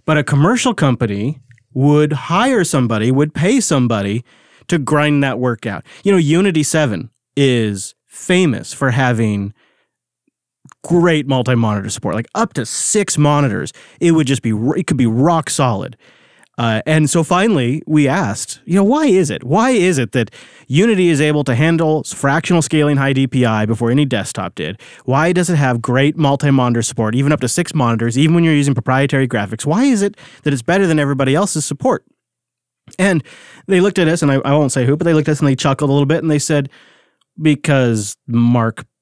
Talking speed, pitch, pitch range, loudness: 190 wpm, 145 Hz, 125-165 Hz, -15 LUFS